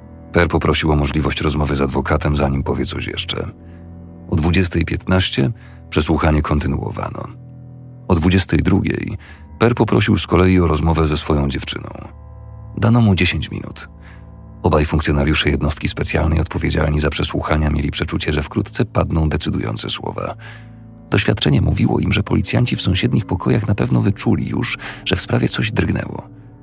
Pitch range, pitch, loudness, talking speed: 75-105 Hz, 85 Hz, -17 LUFS, 135 wpm